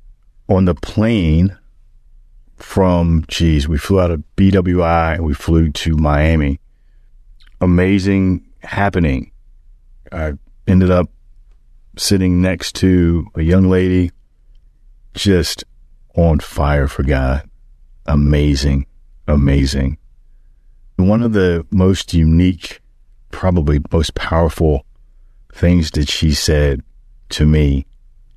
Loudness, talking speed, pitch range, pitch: -15 LUFS, 95 wpm, 70-90 Hz, 80 Hz